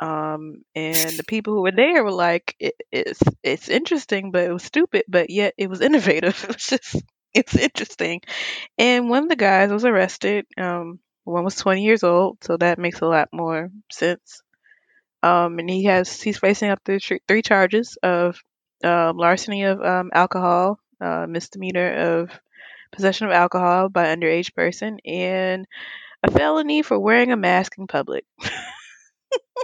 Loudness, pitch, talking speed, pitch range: -20 LUFS, 190 Hz, 170 wpm, 175-215 Hz